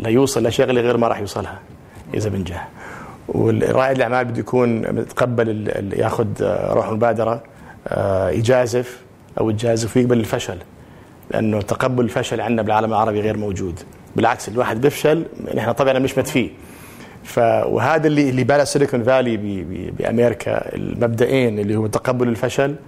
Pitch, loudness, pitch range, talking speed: 120 Hz, -19 LUFS, 110-130 Hz, 130 wpm